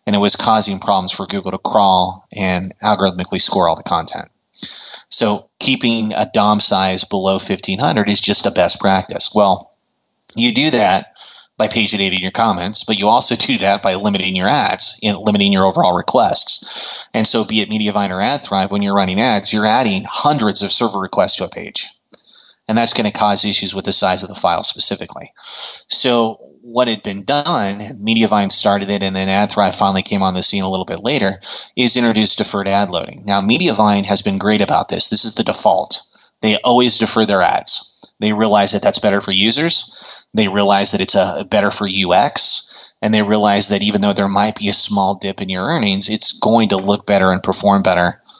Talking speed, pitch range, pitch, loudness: 200 wpm, 100-110 Hz, 100 Hz, -13 LUFS